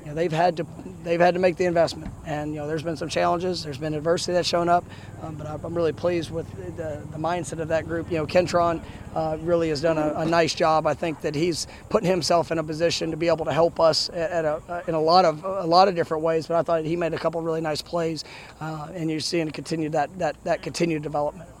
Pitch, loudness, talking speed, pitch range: 165 Hz, -24 LUFS, 265 wpm, 155-170 Hz